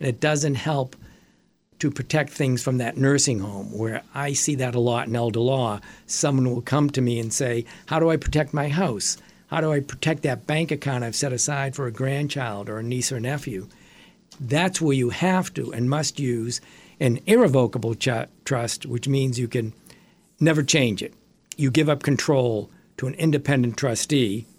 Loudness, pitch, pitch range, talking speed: -23 LUFS, 135 Hz, 120-150 Hz, 190 wpm